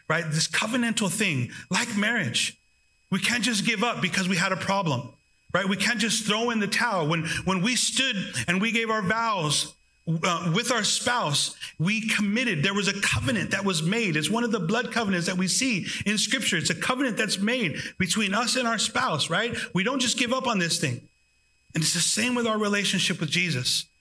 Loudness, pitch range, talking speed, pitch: -24 LUFS, 175-230 Hz, 210 wpm, 200 Hz